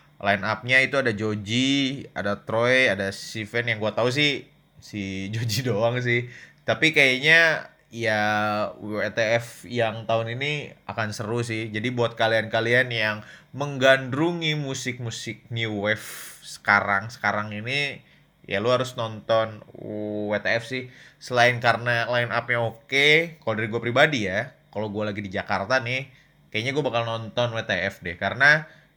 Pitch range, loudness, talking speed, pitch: 110-130 Hz, -23 LUFS, 140 wpm, 115 Hz